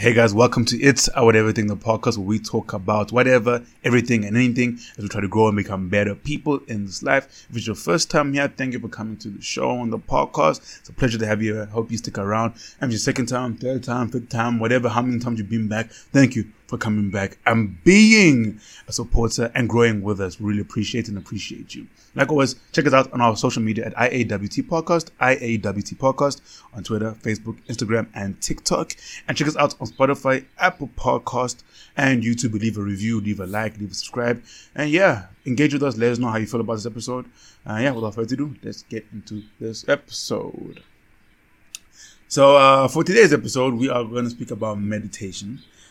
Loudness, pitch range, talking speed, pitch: -20 LUFS, 110-130 Hz, 220 wpm, 115 Hz